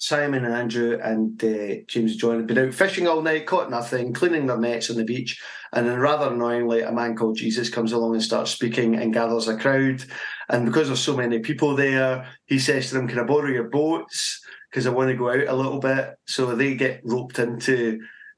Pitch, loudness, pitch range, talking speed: 125 Hz, -23 LUFS, 115-135 Hz, 225 wpm